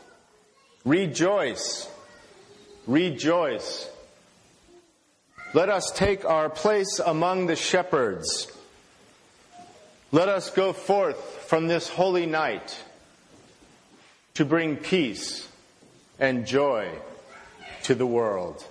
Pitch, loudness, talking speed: 185 Hz, -25 LUFS, 85 wpm